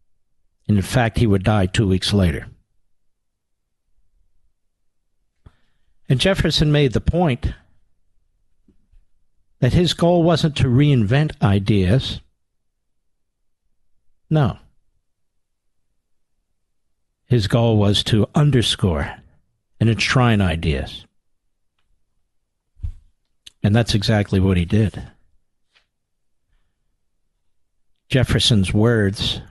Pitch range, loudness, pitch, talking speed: 85-115 Hz, -18 LUFS, 100 Hz, 75 wpm